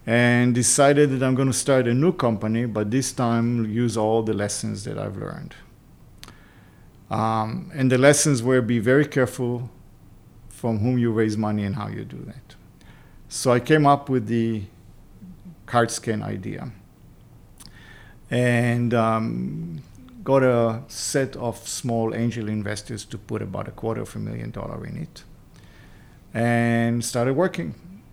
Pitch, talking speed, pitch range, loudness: 115 Hz, 150 wpm, 110-130 Hz, -22 LUFS